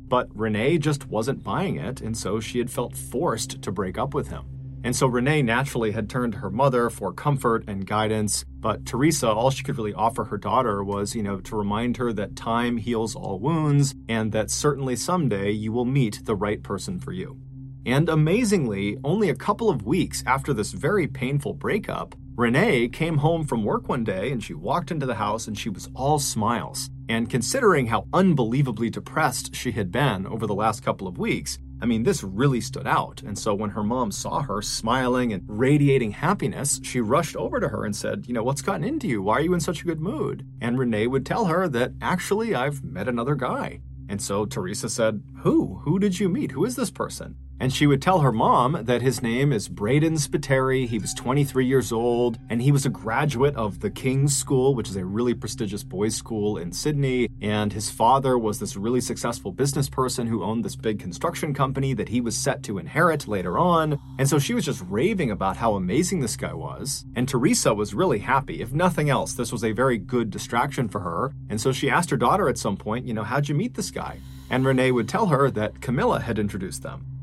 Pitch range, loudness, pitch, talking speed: 110-140 Hz, -24 LUFS, 125 Hz, 220 wpm